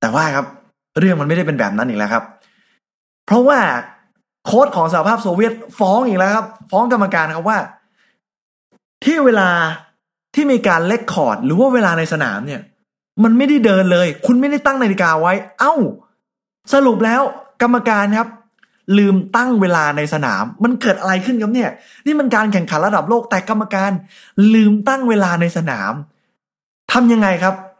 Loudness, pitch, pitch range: -15 LUFS, 210 Hz, 185-240 Hz